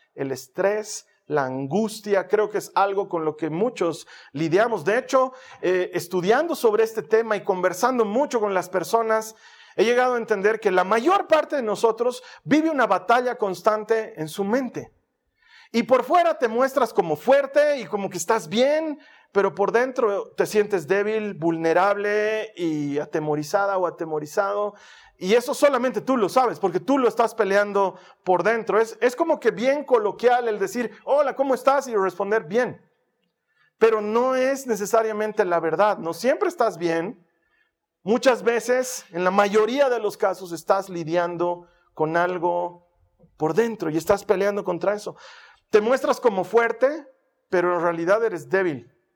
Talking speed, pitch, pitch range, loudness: 160 wpm, 215 Hz, 185-250 Hz, -22 LUFS